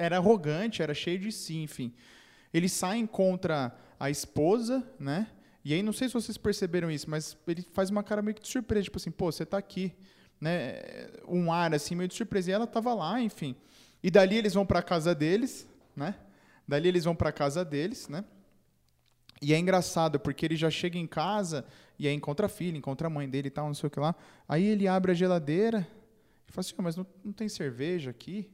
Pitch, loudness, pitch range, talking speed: 175 Hz, -30 LUFS, 155-205 Hz, 220 wpm